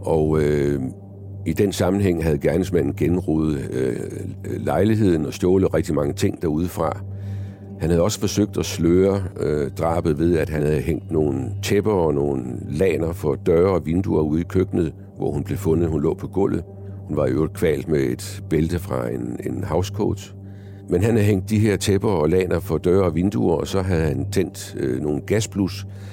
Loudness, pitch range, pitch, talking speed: -21 LUFS, 80-100 Hz, 95 Hz, 185 wpm